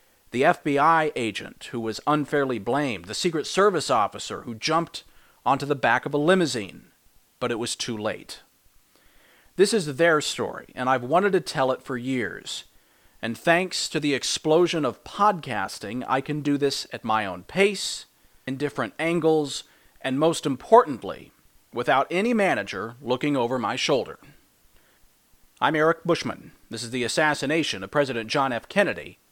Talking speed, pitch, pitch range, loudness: 155 wpm, 145 Hz, 125-165 Hz, -24 LUFS